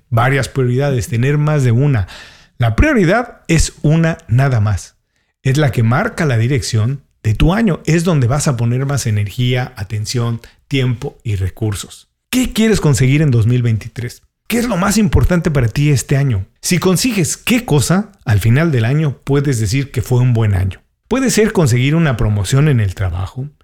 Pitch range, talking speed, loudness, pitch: 115-155 Hz, 175 wpm, -15 LUFS, 135 Hz